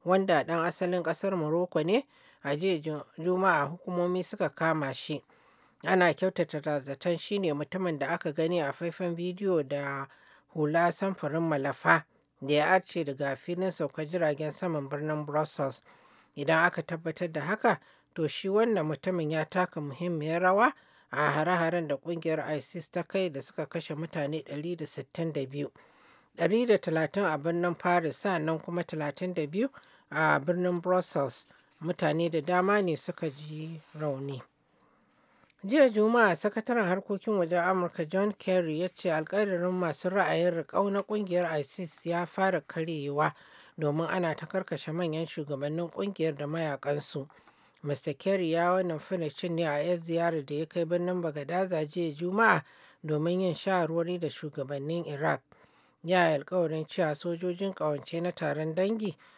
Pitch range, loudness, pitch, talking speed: 155-180 Hz, -30 LUFS, 170 Hz, 135 wpm